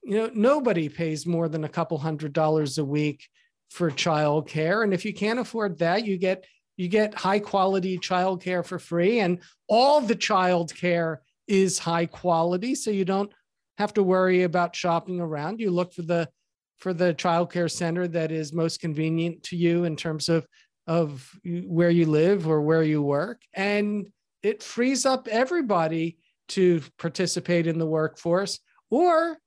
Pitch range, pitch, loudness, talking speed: 165-200 Hz, 175 Hz, -25 LUFS, 175 wpm